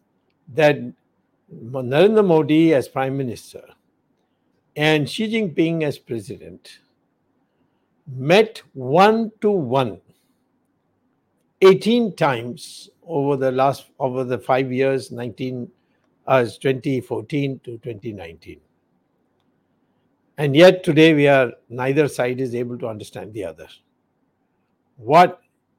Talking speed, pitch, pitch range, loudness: 100 wpm, 135 Hz, 125-160 Hz, -19 LUFS